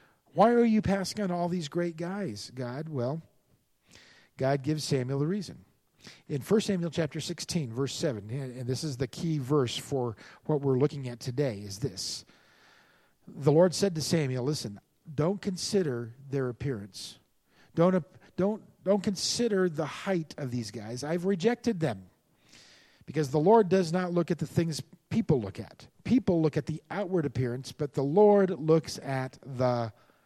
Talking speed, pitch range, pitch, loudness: 165 wpm, 130-180 Hz, 155 Hz, -29 LUFS